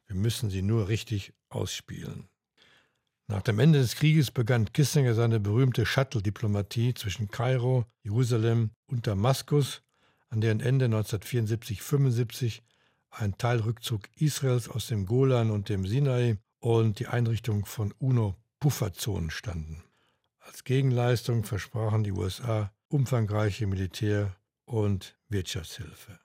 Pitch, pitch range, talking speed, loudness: 115 Hz, 105-130 Hz, 110 wpm, -28 LUFS